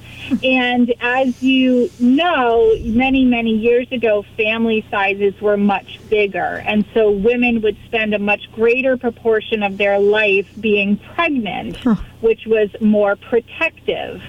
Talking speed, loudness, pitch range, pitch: 130 wpm, -16 LUFS, 210-245 Hz, 225 Hz